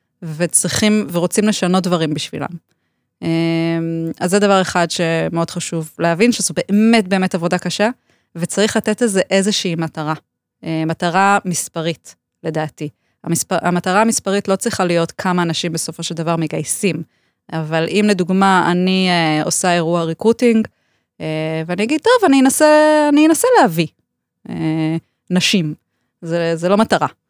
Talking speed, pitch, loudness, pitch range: 130 wpm, 175 Hz, -16 LUFS, 165-205 Hz